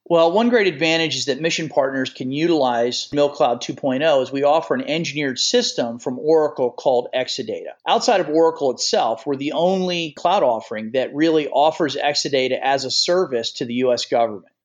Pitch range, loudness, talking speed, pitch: 130-165 Hz, -19 LUFS, 170 wpm, 145 Hz